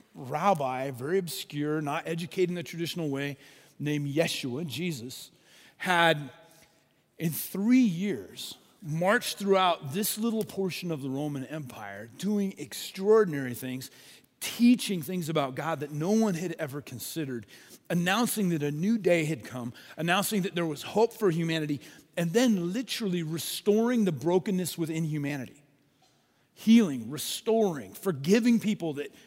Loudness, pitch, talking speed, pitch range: -29 LUFS, 170 Hz, 135 wpm, 145-195 Hz